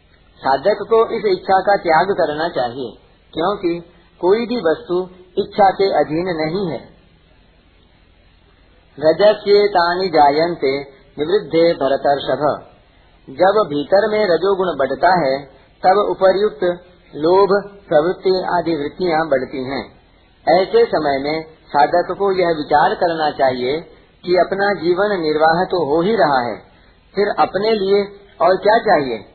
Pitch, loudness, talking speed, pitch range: 175 Hz, -17 LUFS, 120 wpm, 145-195 Hz